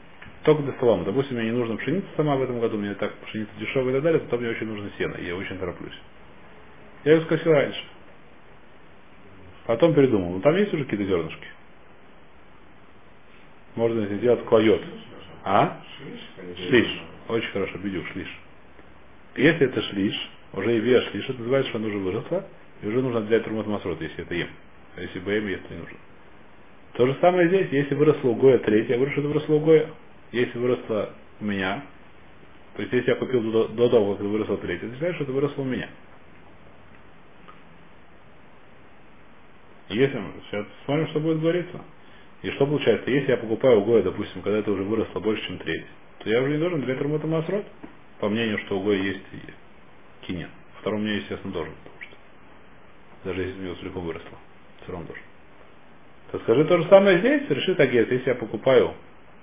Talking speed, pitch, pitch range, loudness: 175 wpm, 115 Hz, 100-145 Hz, -24 LUFS